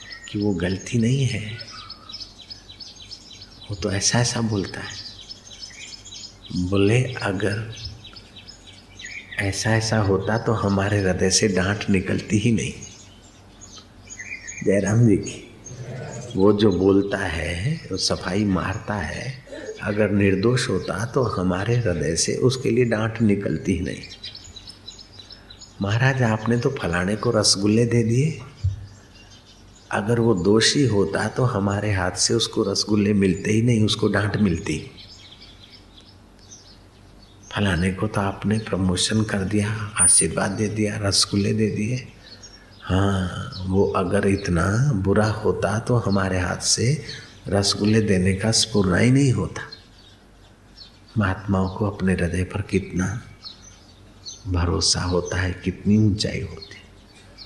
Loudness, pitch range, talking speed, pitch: -21 LUFS, 95-110 Hz, 120 wpm, 100 Hz